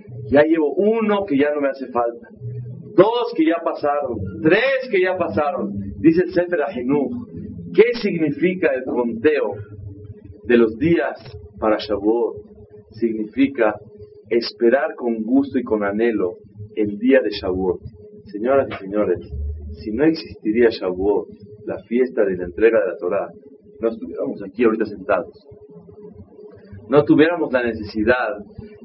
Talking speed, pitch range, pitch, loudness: 135 wpm, 105-160 Hz, 120 Hz, -19 LUFS